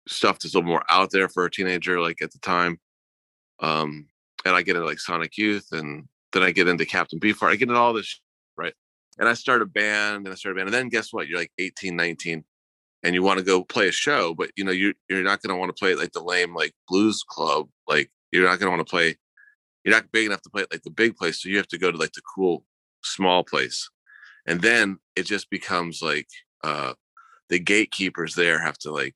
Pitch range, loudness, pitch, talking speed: 85-105 Hz, -23 LUFS, 95 Hz, 250 wpm